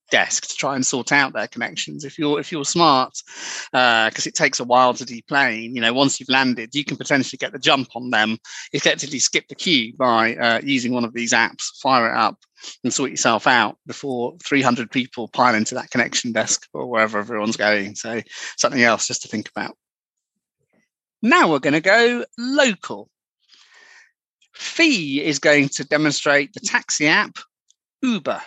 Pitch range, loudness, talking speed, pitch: 120-155 Hz, -19 LUFS, 185 wpm, 135 Hz